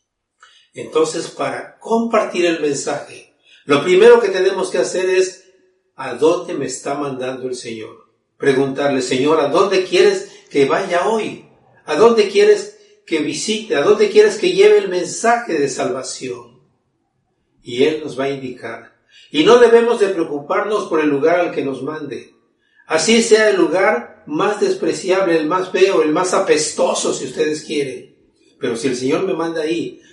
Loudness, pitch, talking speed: -16 LUFS, 195 Hz, 160 wpm